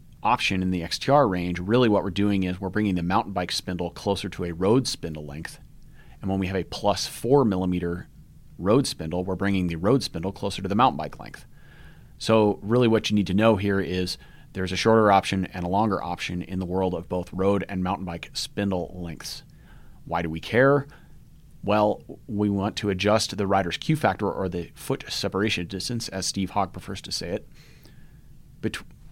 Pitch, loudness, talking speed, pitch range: 95 Hz, -25 LUFS, 200 wpm, 90-105 Hz